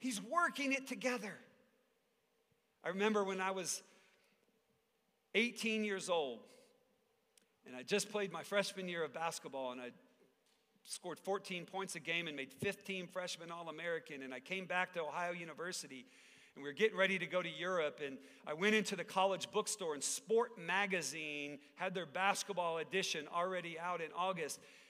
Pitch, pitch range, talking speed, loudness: 185 Hz, 170-205 Hz, 165 wpm, -39 LUFS